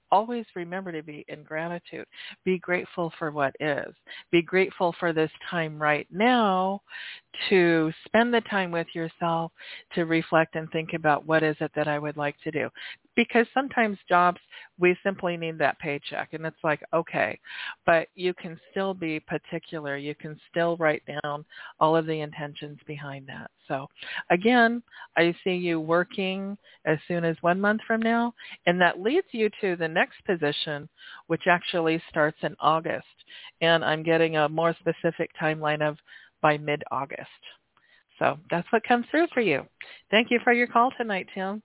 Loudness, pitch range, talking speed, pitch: -26 LUFS, 155-195 Hz, 170 wpm, 170 Hz